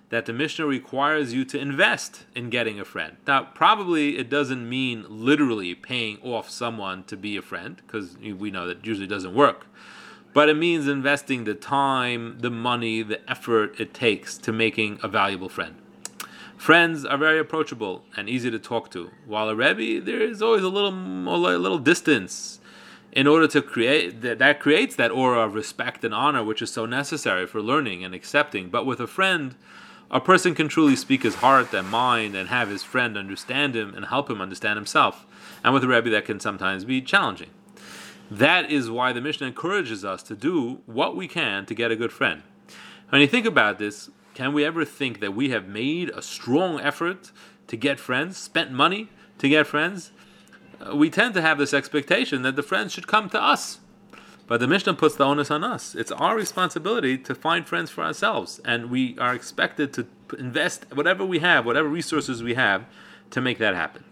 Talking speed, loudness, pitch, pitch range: 195 wpm, -23 LUFS, 130 Hz, 110-155 Hz